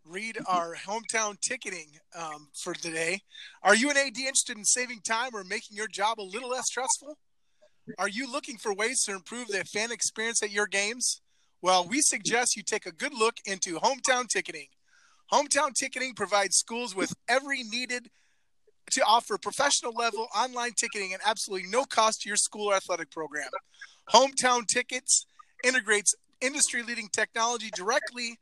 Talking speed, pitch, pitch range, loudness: 160 wpm, 225 Hz, 200-250 Hz, -27 LUFS